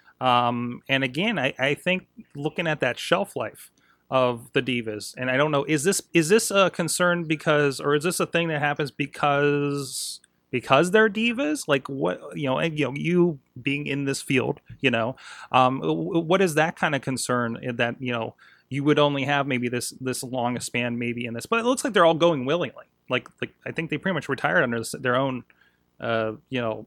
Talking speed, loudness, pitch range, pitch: 210 wpm, -24 LUFS, 125-165 Hz, 140 Hz